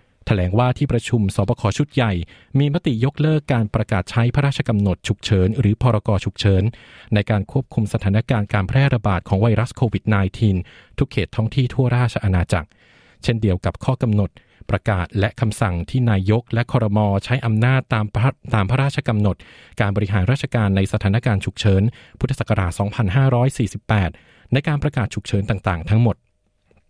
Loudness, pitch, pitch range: -20 LUFS, 110 Hz, 100-125 Hz